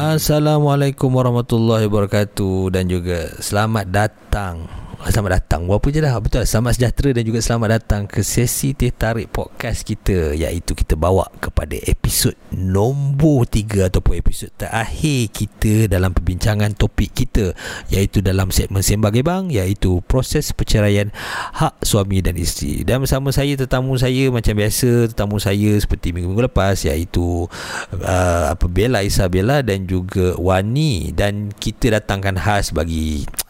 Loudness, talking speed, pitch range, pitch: -18 LUFS, 135 wpm, 95-120 Hz, 105 Hz